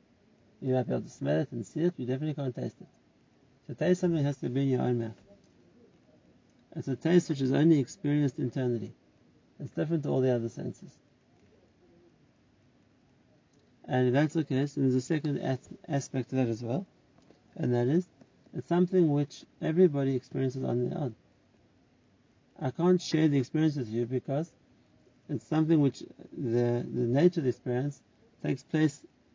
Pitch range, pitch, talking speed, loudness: 125-155 Hz, 135 Hz, 170 wpm, -30 LUFS